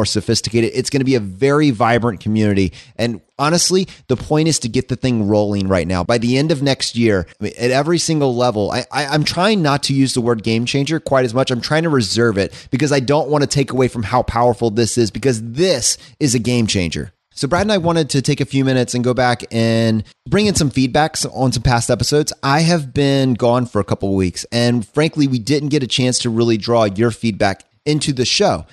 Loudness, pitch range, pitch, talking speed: -16 LUFS, 115-145 Hz, 125 Hz, 235 wpm